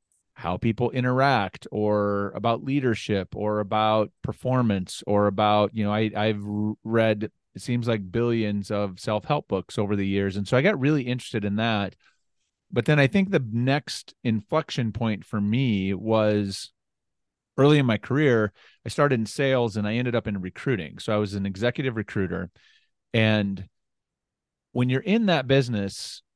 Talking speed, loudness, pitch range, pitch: 165 wpm, -25 LUFS, 105-125 Hz, 110 Hz